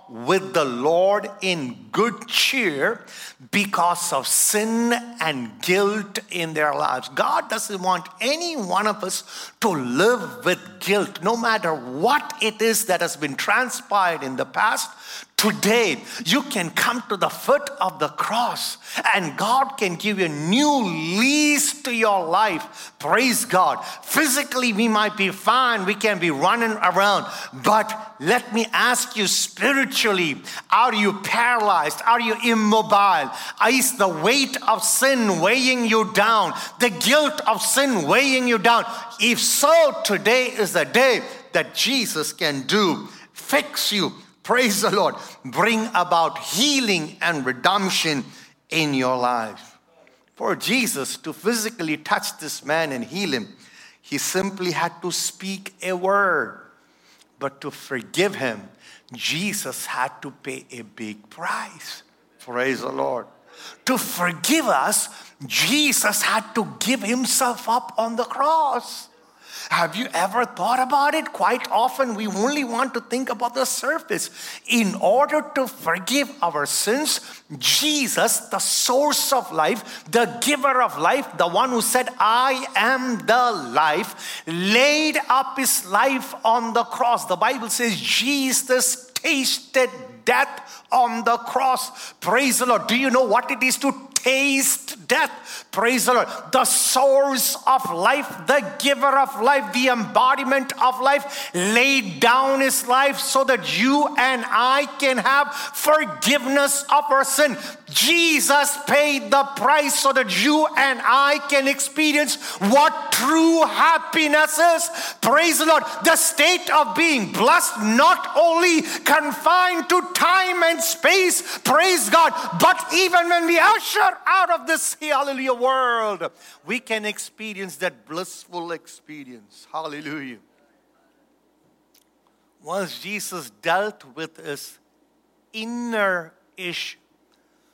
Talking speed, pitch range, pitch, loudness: 140 wpm, 200-280 Hz, 245 Hz, -20 LUFS